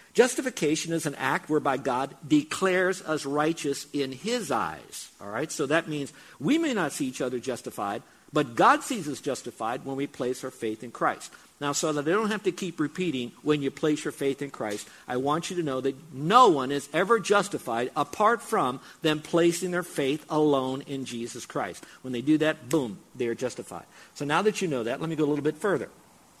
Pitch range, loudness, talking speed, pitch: 135-170 Hz, -27 LUFS, 210 wpm, 150 Hz